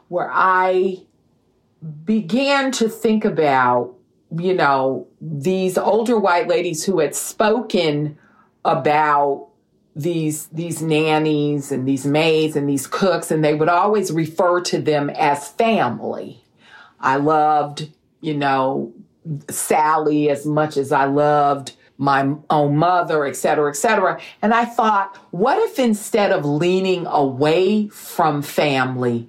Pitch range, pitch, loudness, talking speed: 145-185 Hz, 155 Hz, -18 LUFS, 125 wpm